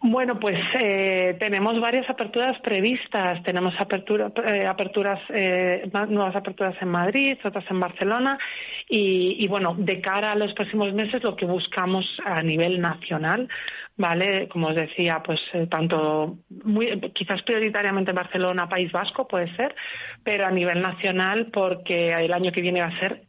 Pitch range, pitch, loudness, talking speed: 180-215 Hz, 195 Hz, -24 LUFS, 160 wpm